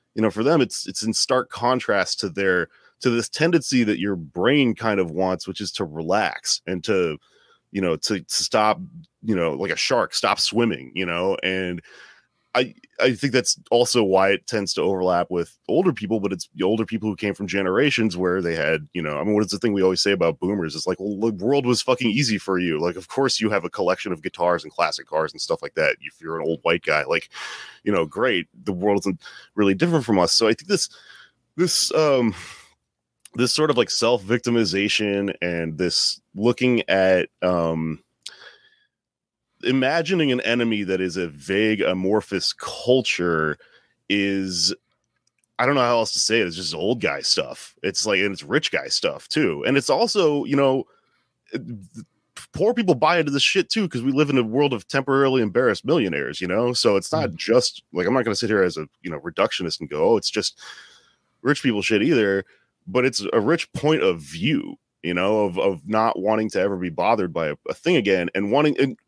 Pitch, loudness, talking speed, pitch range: 105 Hz, -21 LUFS, 210 wpm, 95-130 Hz